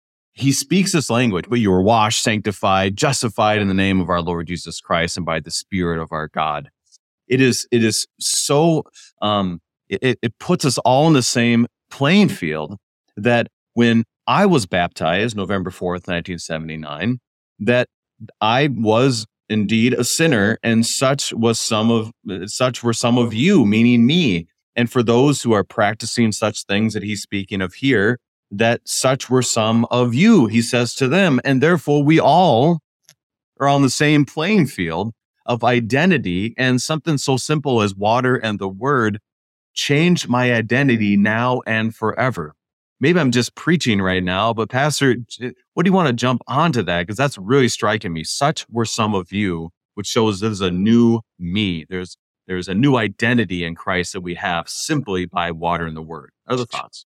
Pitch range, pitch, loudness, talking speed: 95-130 Hz, 115 Hz, -18 LUFS, 180 wpm